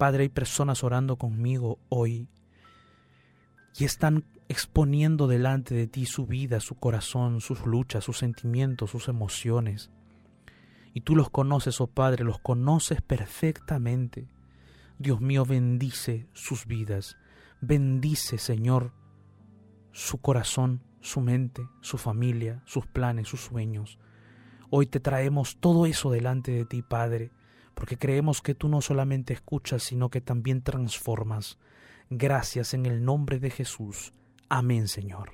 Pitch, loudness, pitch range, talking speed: 125 Hz, -28 LUFS, 115-135 Hz, 130 wpm